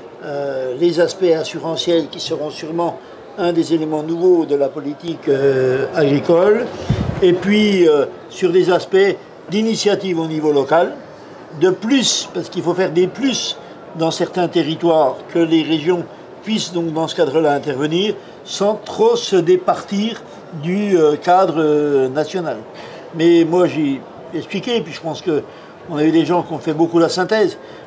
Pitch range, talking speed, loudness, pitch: 155-190 Hz, 160 wpm, -17 LUFS, 170 Hz